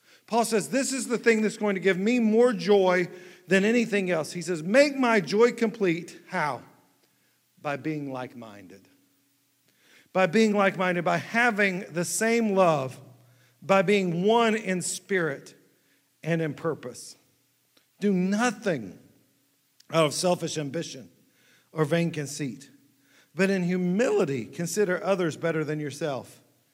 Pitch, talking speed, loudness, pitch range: 180 Hz, 130 wpm, -25 LUFS, 145-205 Hz